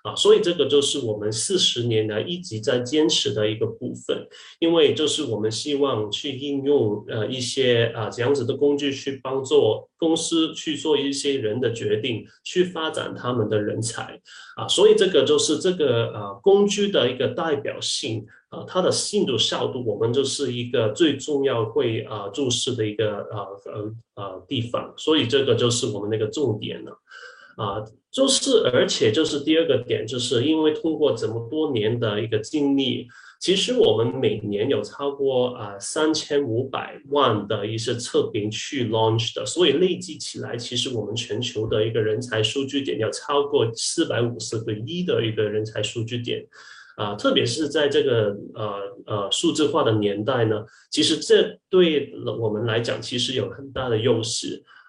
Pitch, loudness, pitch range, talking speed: 135 Hz, -22 LUFS, 110-155 Hz, 275 characters per minute